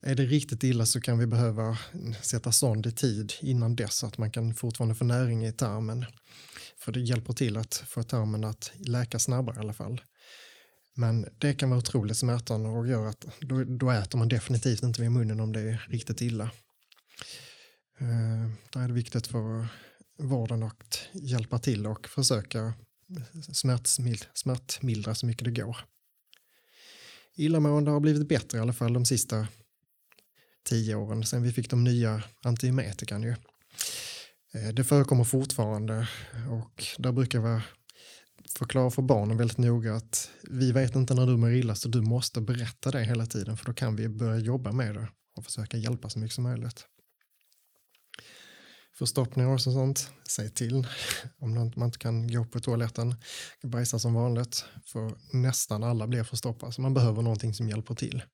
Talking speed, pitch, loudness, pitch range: 170 wpm, 120 Hz, -29 LUFS, 115-130 Hz